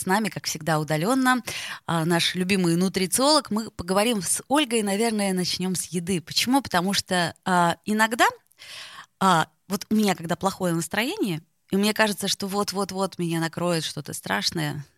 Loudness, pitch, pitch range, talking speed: -24 LUFS, 190 Hz, 170-210 Hz, 150 wpm